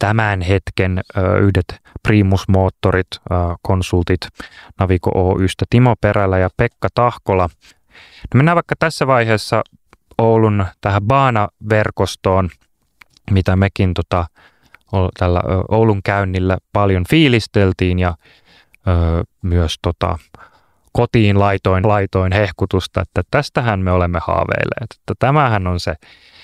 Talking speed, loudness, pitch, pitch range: 105 wpm, -16 LUFS, 95 Hz, 90-110 Hz